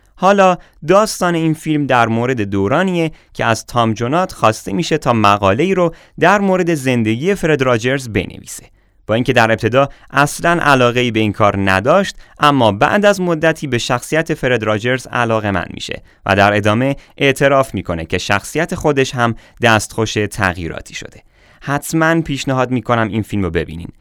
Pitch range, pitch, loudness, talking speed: 110-160 Hz, 125 Hz, -15 LUFS, 160 wpm